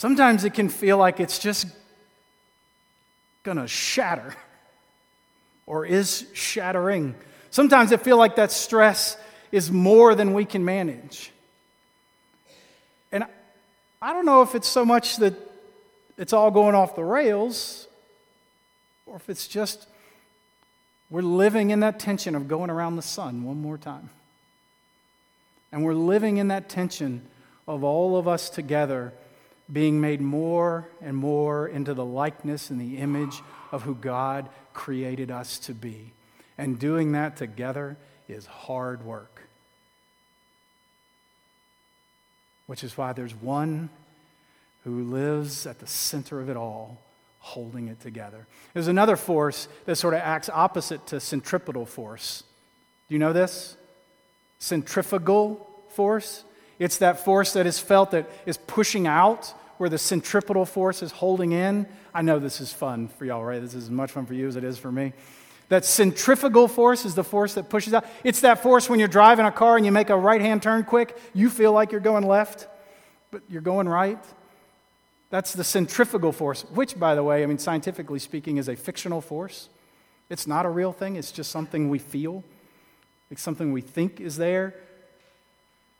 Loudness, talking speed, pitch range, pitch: -23 LUFS, 160 wpm, 145-205 Hz, 175 Hz